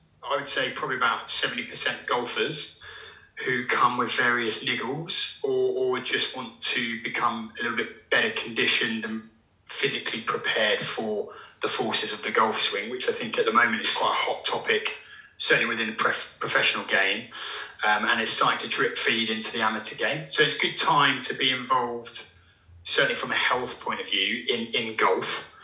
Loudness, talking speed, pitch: -24 LUFS, 185 wpm, 115 Hz